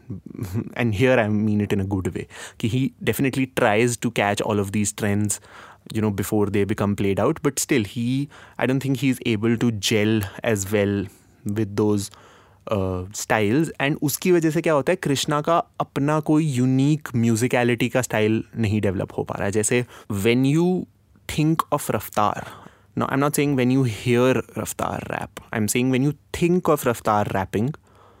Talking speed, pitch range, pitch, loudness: 180 wpm, 105-135 Hz, 120 Hz, -22 LUFS